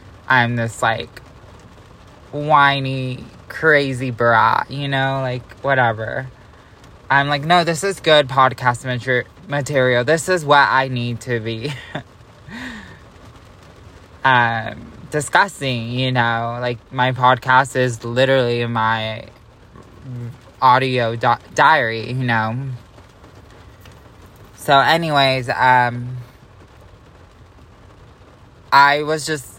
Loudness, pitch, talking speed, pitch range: -17 LUFS, 125 Hz, 95 wpm, 110-135 Hz